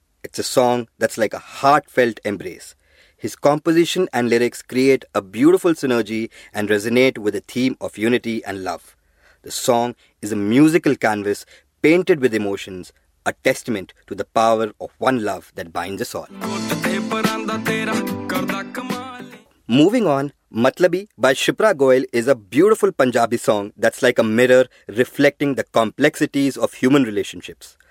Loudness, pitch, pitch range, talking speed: -19 LUFS, 125 Hz, 115-145 Hz, 145 wpm